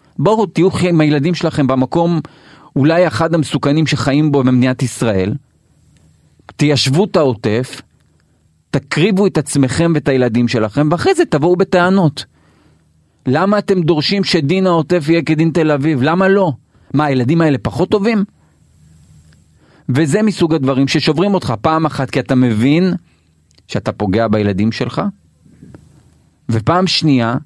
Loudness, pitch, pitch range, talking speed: -14 LUFS, 145 Hz, 115-170 Hz, 125 wpm